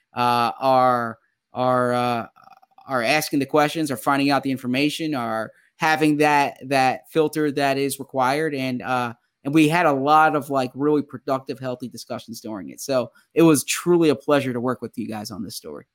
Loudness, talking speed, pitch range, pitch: -21 LUFS, 190 wpm, 125-150 Hz, 135 Hz